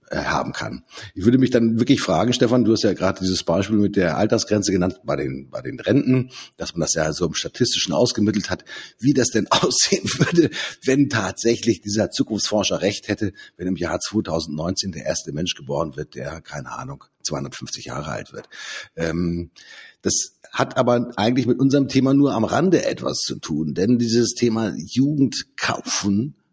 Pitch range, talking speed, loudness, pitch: 95-125 Hz, 175 wpm, -21 LUFS, 110 Hz